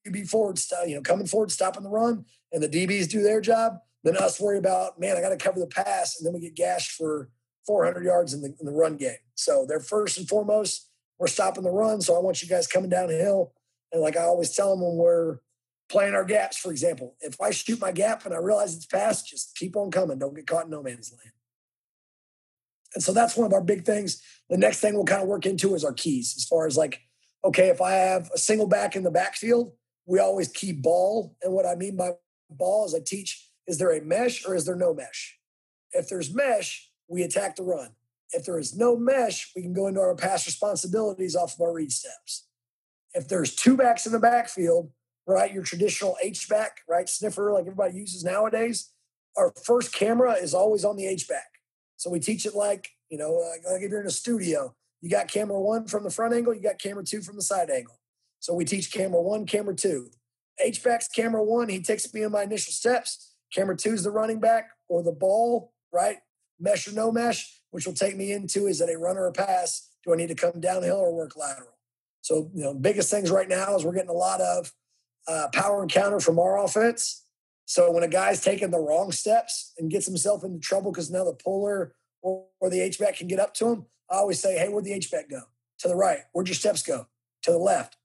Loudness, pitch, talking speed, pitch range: -26 LUFS, 185 Hz, 230 wpm, 165-210 Hz